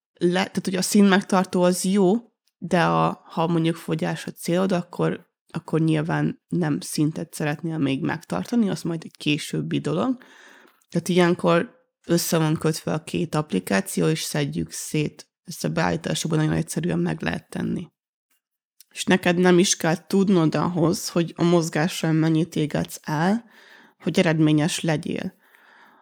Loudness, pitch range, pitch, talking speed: -23 LUFS, 160-185 Hz, 170 Hz, 145 wpm